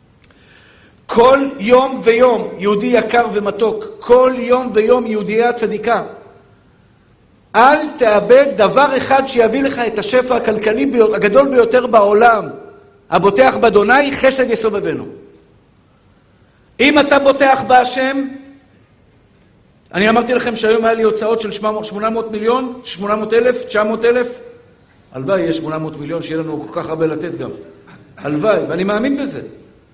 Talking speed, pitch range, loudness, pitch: 120 wpm, 210-255 Hz, -14 LUFS, 225 Hz